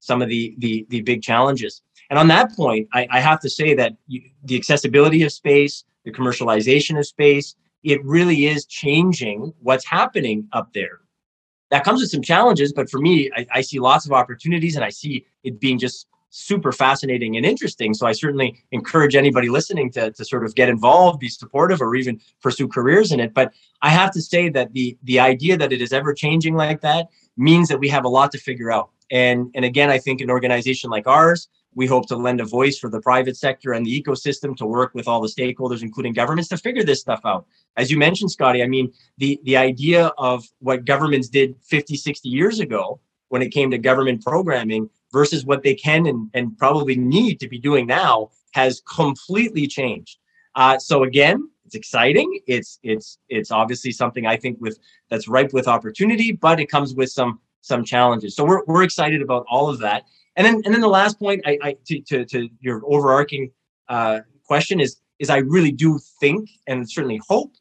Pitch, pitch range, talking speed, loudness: 135 Hz, 125-150 Hz, 205 wpm, -18 LUFS